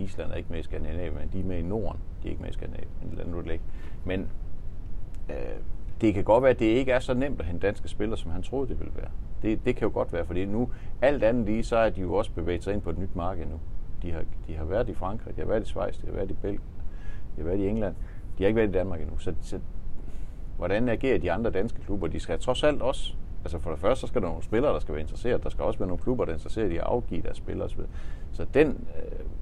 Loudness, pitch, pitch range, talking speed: -29 LUFS, 90 Hz, 80-105 Hz, 290 wpm